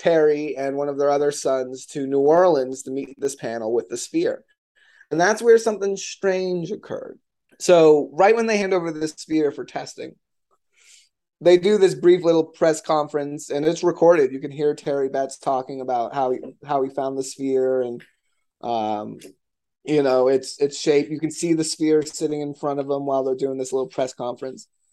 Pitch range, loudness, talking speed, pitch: 135-170 Hz, -21 LUFS, 195 wpm, 150 Hz